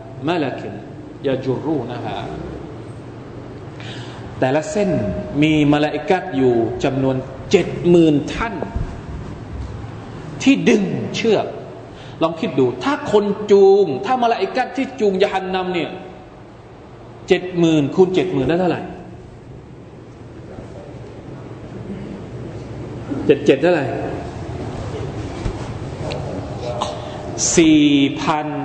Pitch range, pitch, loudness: 130-185 Hz, 150 Hz, -18 LUFS